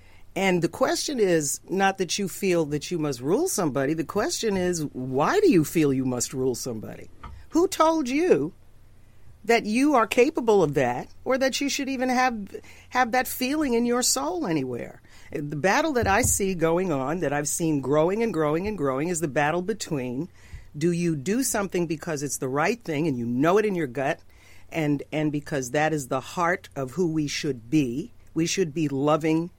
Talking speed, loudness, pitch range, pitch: 195 wpm, -25 LUFS, 145-225 Hz, 165 Hz